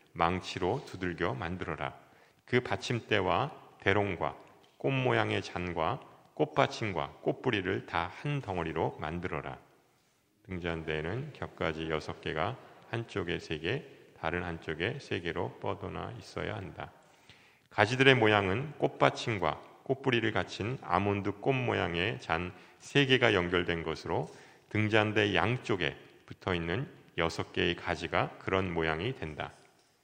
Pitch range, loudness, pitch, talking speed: 85-115 Hz, -32 LUFS, 95 Hz, 265 characters per minute